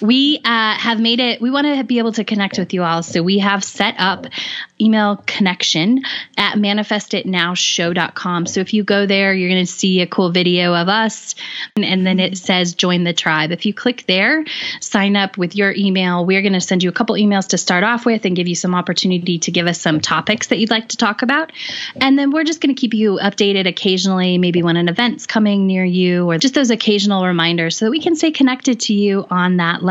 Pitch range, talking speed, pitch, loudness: 180-230 Hz, 235 wpm, 200 Hz, -15 LUFS